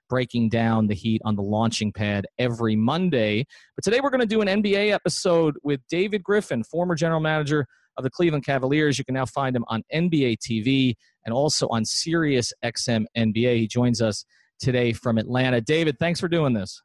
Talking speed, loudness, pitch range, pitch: 190 wpm, -23 LUFS, 115-160 Hz, 130 Hz